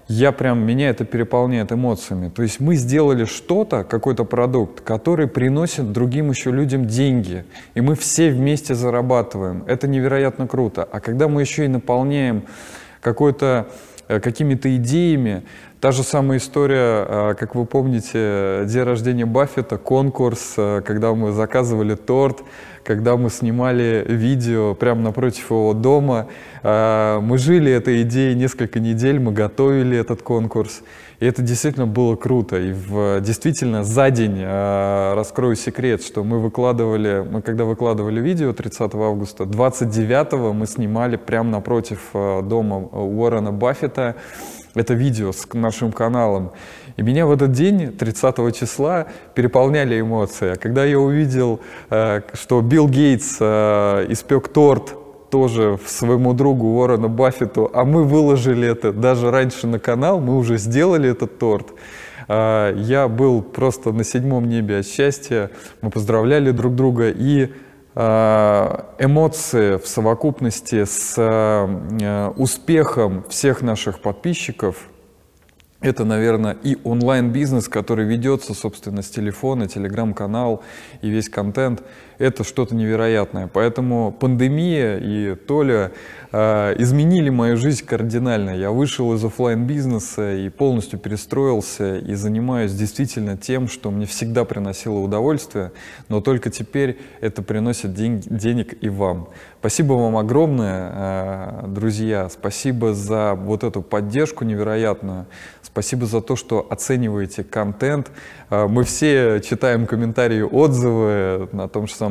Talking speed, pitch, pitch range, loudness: 125 wpm, 115 Hz, 105-130 Hz, -19 LUFS